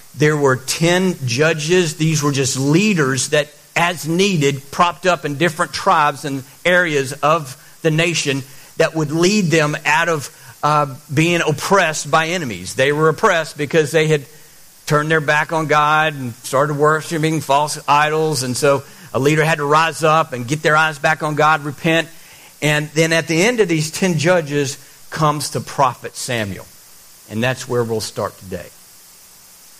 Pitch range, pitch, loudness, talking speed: 145-165 Hz, 155 Hz, -17 LUFS, 165 wpm